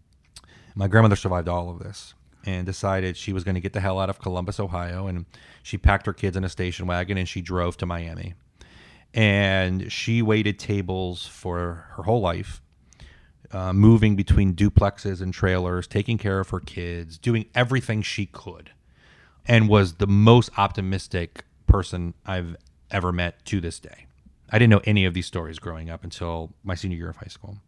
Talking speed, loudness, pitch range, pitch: 180 wpm, -23 LUFS, 85-100 Hz, 95 Hz